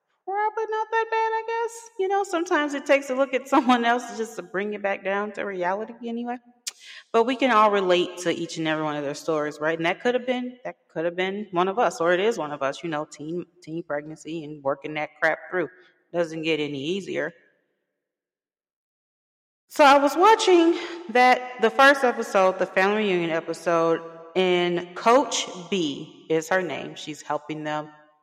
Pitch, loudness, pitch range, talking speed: 185 Hz, -23 LUFS, 165-250 Hz, 195 wpm